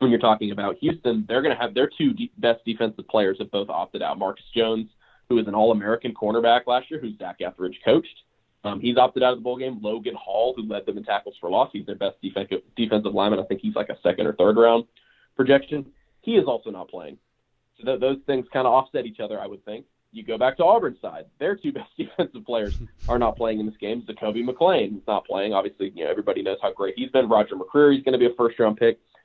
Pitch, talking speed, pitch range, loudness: 115 Hz, 255 wpm, 110-130 Hz, -23 LUFS